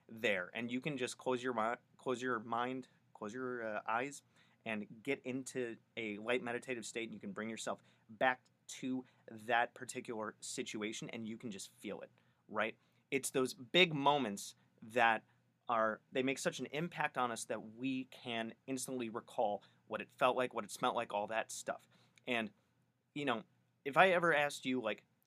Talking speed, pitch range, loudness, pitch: 180 wpm, 110-130 Hz, -38 LUFS, 125 Hz